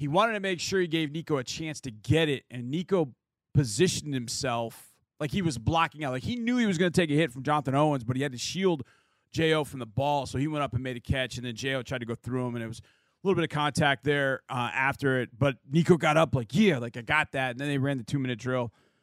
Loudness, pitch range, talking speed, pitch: -28 LUFS, 125-160 Hz, 285 wpm, 140 Hz